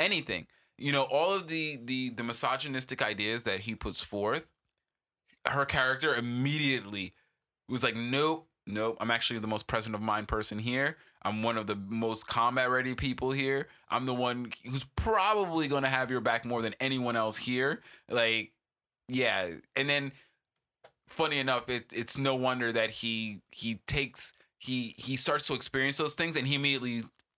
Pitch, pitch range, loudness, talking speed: 125 Hz, 115-135 Hz, -31 LUFS, 170 wpm